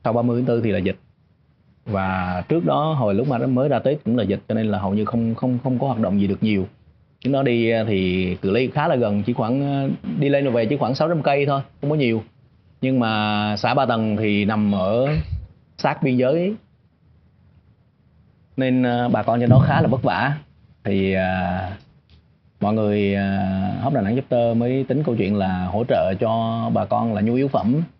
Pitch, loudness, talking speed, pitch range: 115 Hz, -21 LUFS, 215 wpm, 100-130 Hz